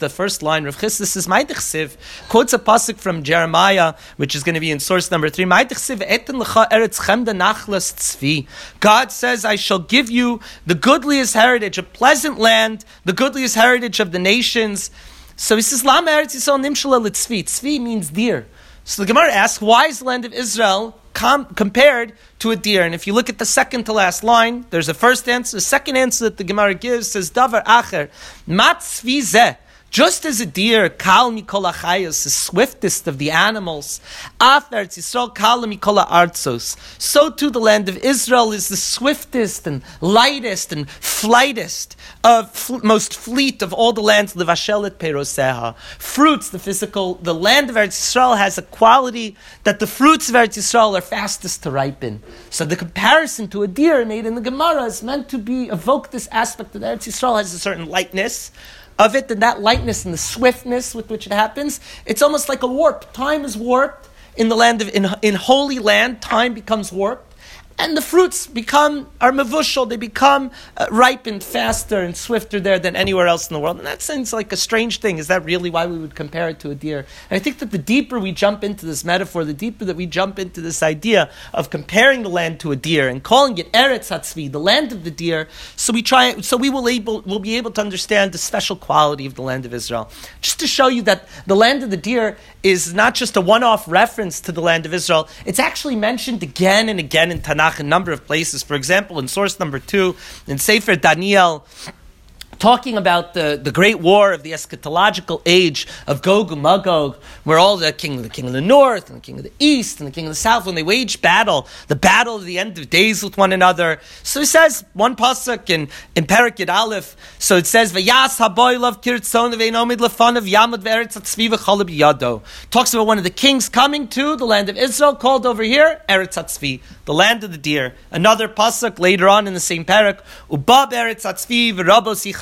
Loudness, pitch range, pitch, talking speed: -16 LUFS, 180-245 Hz, 215 Hz, 200 wpm